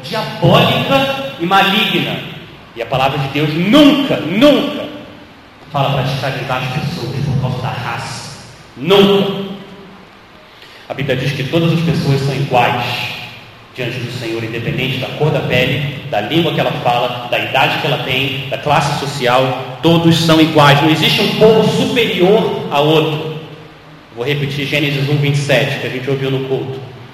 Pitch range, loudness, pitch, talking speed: 130-165 Hz, -14 LUFS, 145 Hz, 155 wpm